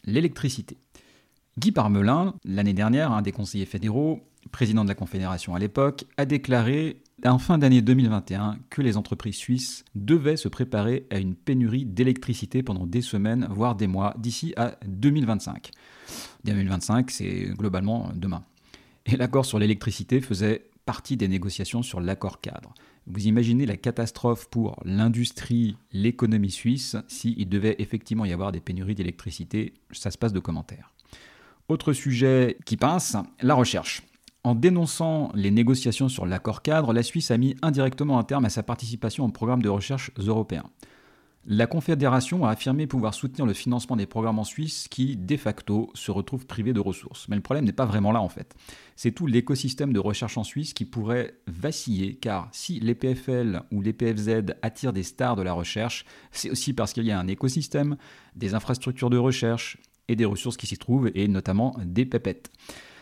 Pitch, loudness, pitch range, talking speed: 115 Hz, -26 LUFS, 105-130 Hz, 170 wpm